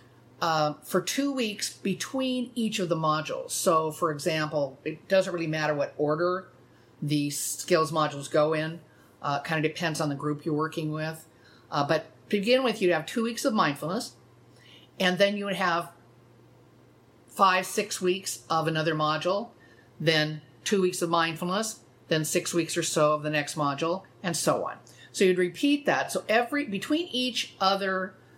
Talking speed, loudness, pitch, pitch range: 170 wpm, -27 LUFS, 165 Hz, 150-190 Hz